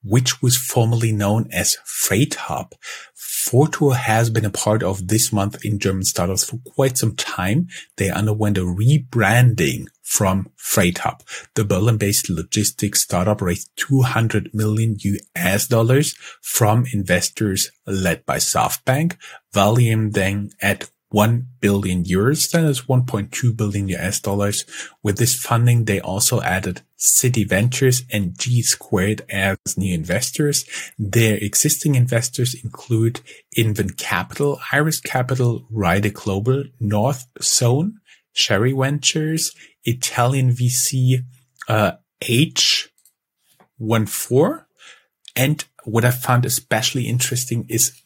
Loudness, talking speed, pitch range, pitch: -19 LUFS, 120 wpm, 105-130 Hz, 115 Hz